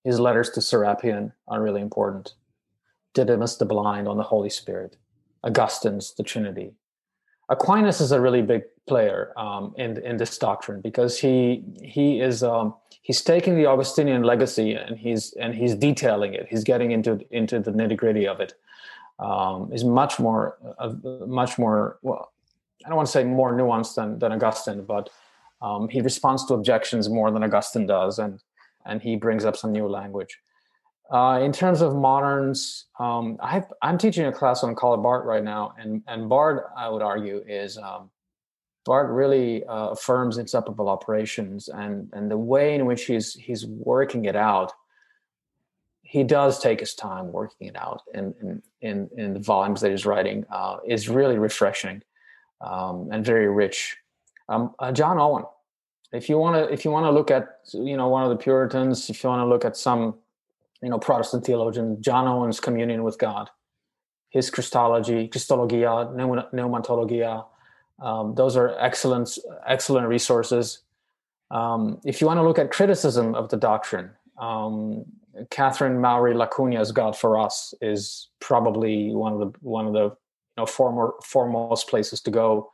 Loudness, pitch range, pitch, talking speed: -23 LUFS, 110-130 Hz, 120 Hz, 170 wpm